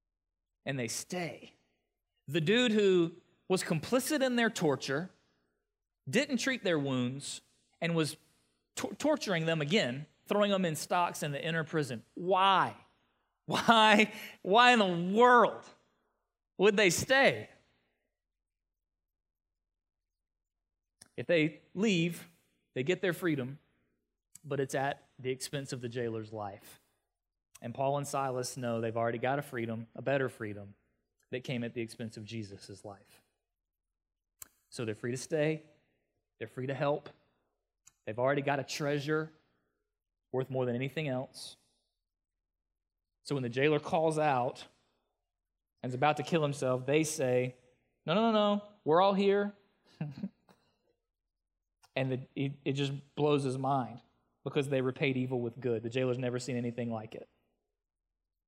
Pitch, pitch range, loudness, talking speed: 130 Hz, 100-165 Hz, -31 LUFS, 135 wpm